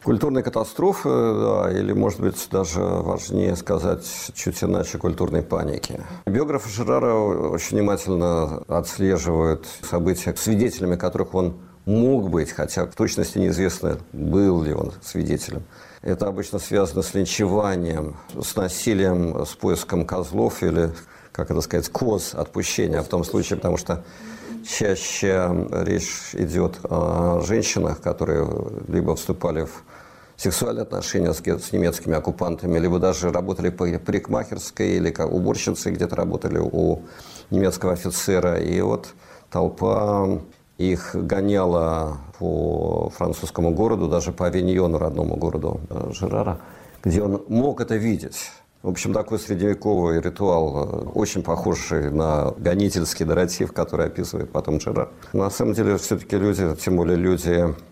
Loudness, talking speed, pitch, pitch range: -23 LUFS, 125 wpm, 90 Hz, 85-100 Hz